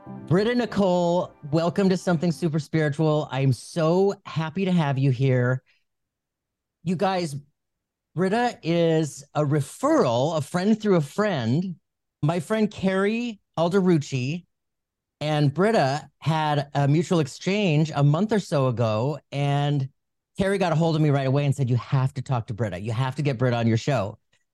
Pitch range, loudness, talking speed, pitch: 135-180 Hz, -24 LUFS, 160 wpm, 150 Hz